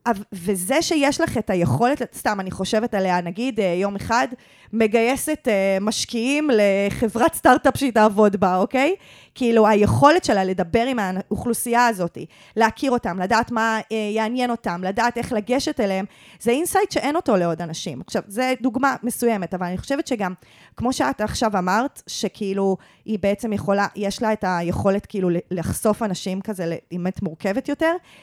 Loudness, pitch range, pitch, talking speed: -21 LUFS, 195-250 Hz, 220 Hz, 150 wpm